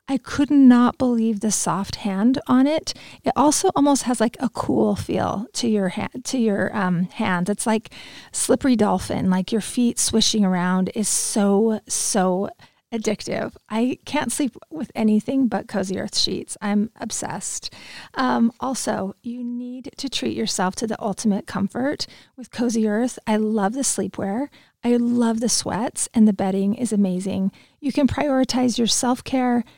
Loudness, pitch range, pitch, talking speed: -21 LUFS, 205-255 Hz, 225 Hz, 165 wpm